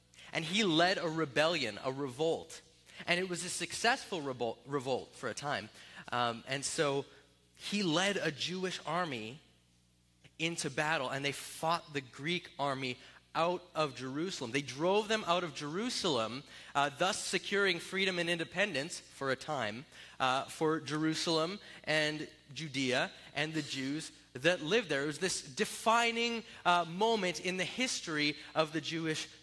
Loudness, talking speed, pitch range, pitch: -34 LUFS, 150 wpm, 135-180 Hz, 155 Hz